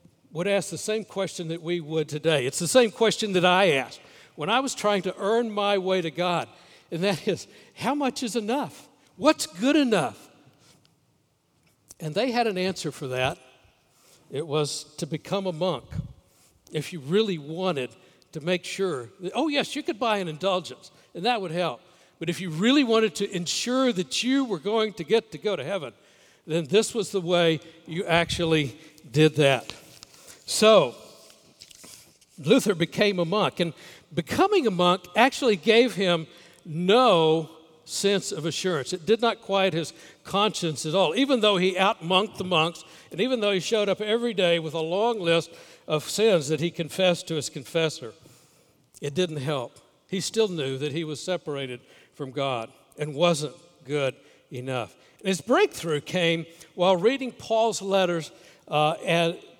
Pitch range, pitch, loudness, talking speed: 155-210 Hz, 175 Hz, -25 LUFS, 170 wpm